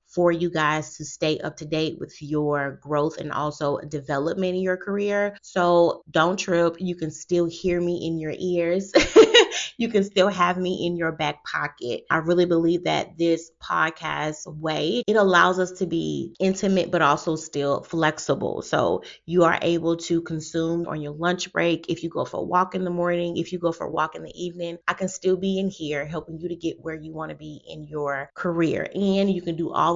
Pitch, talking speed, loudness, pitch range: 170 Hz, 210 wpm, -23 LUFS, 155-180 Hz